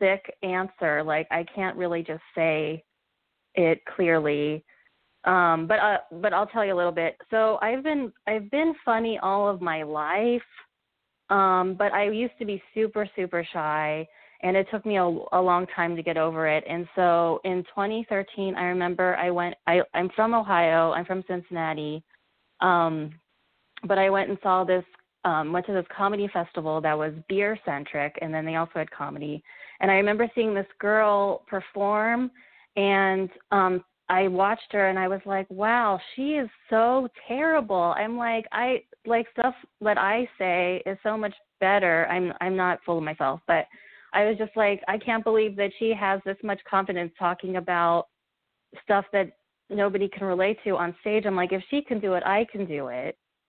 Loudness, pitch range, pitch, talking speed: -25 LUFS, 175-210 Hz, 190 Hz, 180 wpm